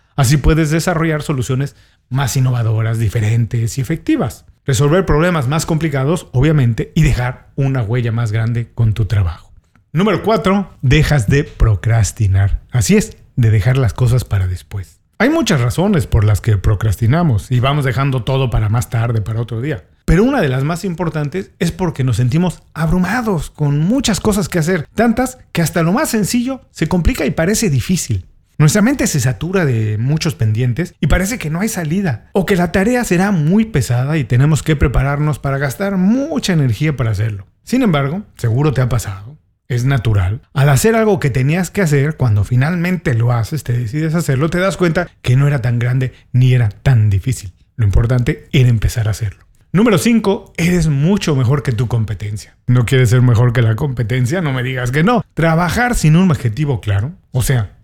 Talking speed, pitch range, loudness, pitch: 185 wpm, 115-170 Hz, -15 LUFS, 140 Hz